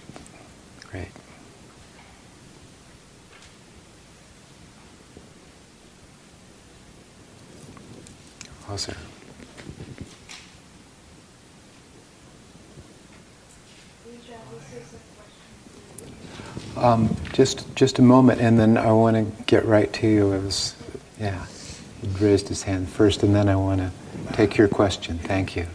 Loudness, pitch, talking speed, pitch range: -21 LUFS, 105 Hz, 75 wpm, 95-115 Hz